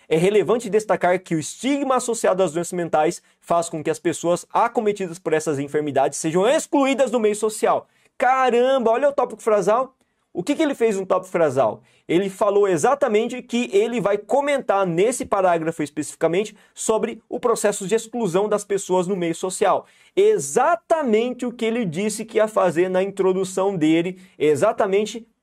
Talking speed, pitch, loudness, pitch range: 165 wpm, 205 Hz, -21 LUFS, 175-235 Hz